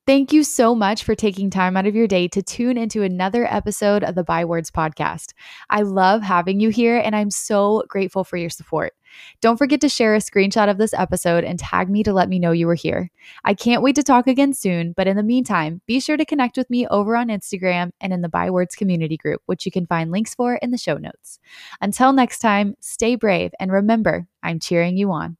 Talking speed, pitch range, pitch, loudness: 230 wpm, 180-235 Hz, 205 Hz, -19 LUFS